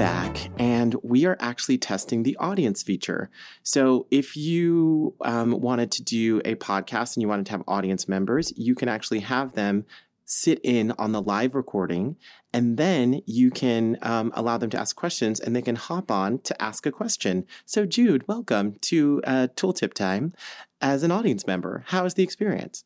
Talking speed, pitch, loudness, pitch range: 185 wpm, 120 Hz, -25 LUFS, 110-150 Hz